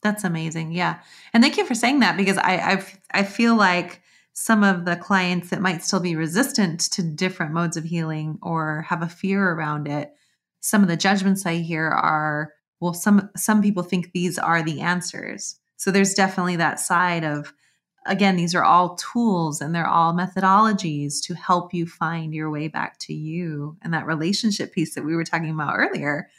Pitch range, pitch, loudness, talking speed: 160-195 Hz, 175 Hz, -22 LUFS, 195 wpm